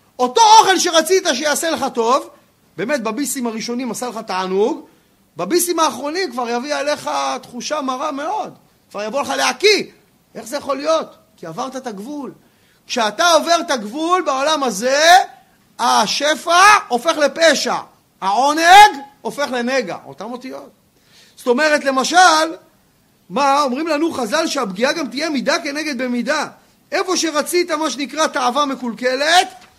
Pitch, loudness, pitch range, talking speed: 290 Hz, -16 LUFS, 250-320 Hz, 130 wpm